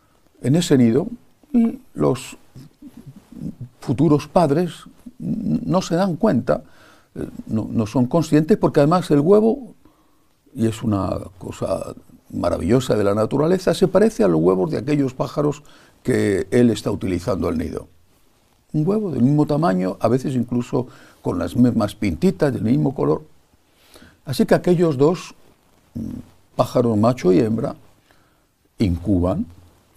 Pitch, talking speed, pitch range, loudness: 145 Hz, 130 wpm, 115-180 Hz, -19 LUFS